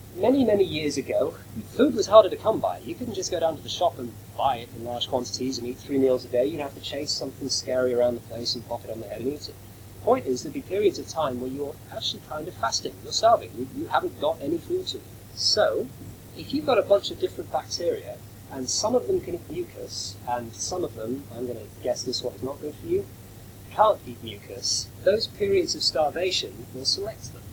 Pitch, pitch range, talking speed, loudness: 130 Hz, 120-185 Hz, 240 wpm, -26 LUFS